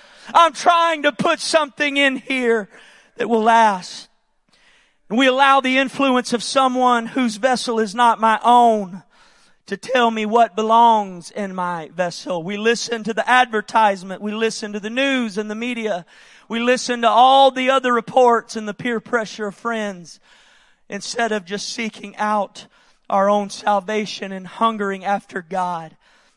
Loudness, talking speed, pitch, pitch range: -18 LUFS, 155 wpm, 225 Hz, 205-250 Hz